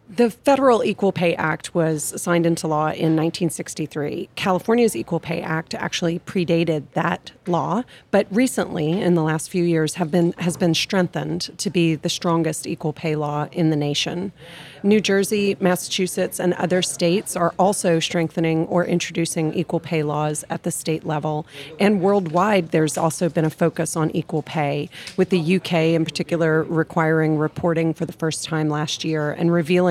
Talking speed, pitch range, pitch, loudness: 170 wpm, 160-180 Hz, 170 Hz, -21 LUFS